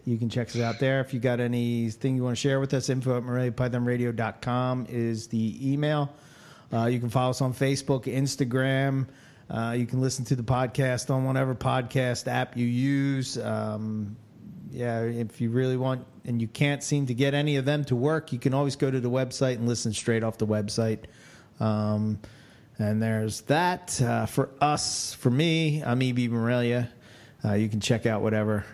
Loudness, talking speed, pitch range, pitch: -27 LUFS, 190 wpm, 115-135 Hz, 125 Hz